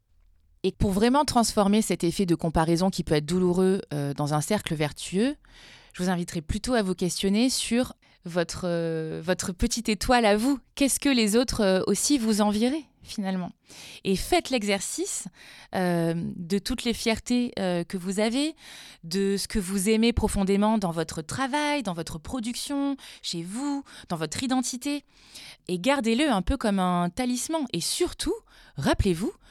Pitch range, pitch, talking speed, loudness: 180-255 Hz, 205 Hz, 165 wpm, -26 LUFS